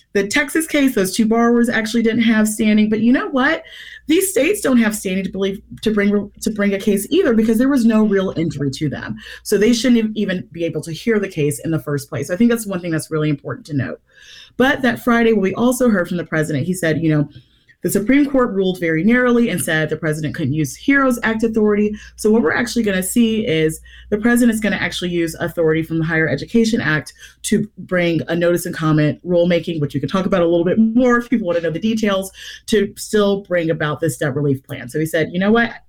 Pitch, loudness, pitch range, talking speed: 195 Hz, -17 LUFS, 160-230 Hz, 245 wpm